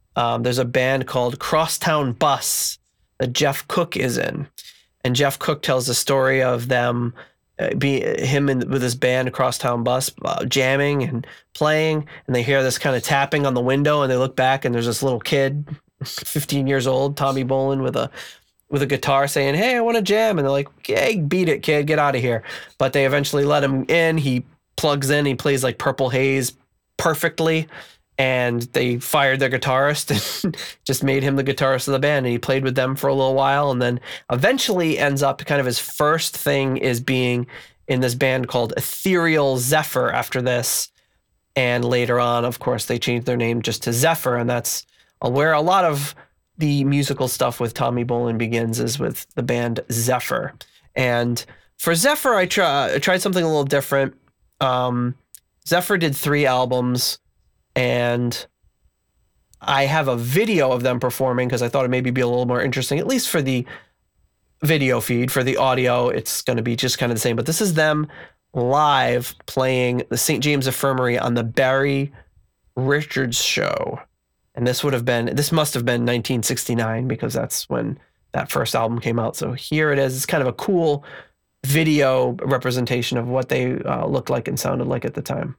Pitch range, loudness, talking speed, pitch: 125-145 Hz, -20 LUFS, 195 wpm, 135 Hz